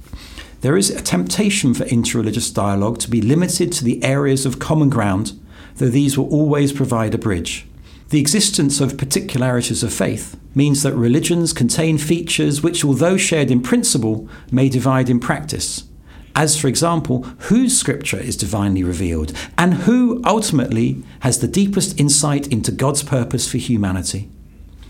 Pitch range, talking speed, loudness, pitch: 105-150 Hz, 150 wpm, -17 LUFS, 130 Hz